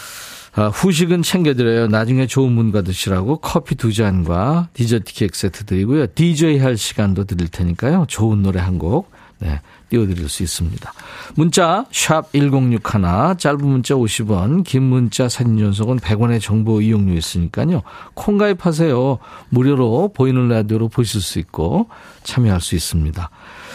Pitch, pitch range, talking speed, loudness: 115 Hz, 100-140 Hz, 300 characters per minute, -17 LUFS